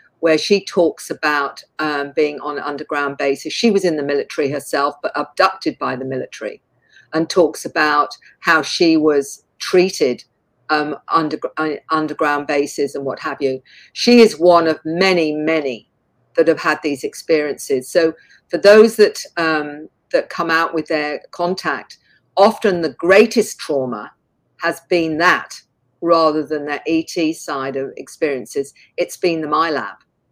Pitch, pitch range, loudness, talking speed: 160 Hz, 145-175 Hz, -17 LUFS, 150 wpm